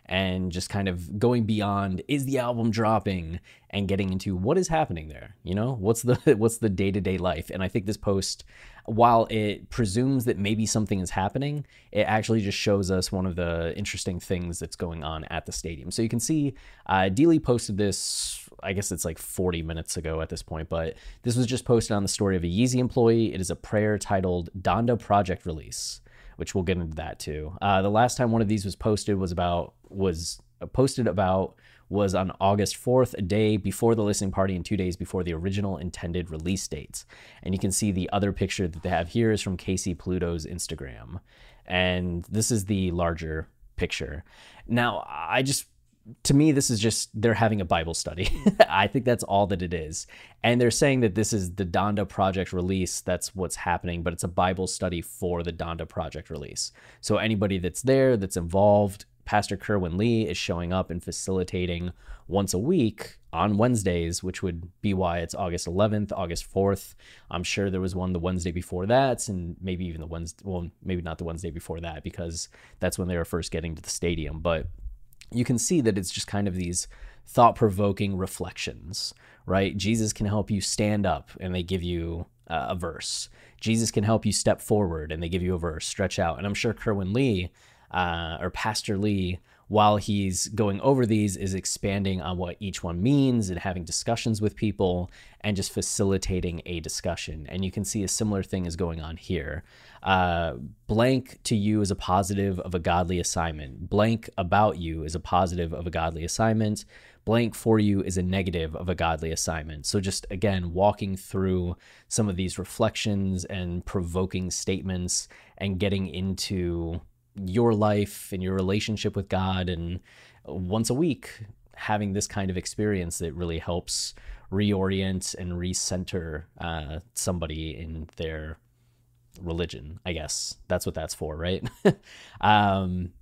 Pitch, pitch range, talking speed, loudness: 95 Hz, 90-105 Hz, 190 wpm, -27 LUFS